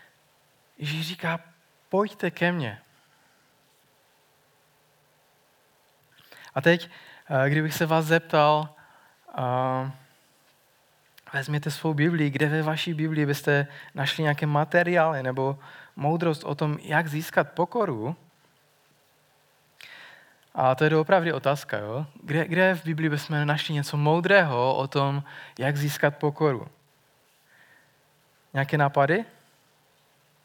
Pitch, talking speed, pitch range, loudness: 150 Hz, 100 wpm, 140-160 Hz, -25 LUFS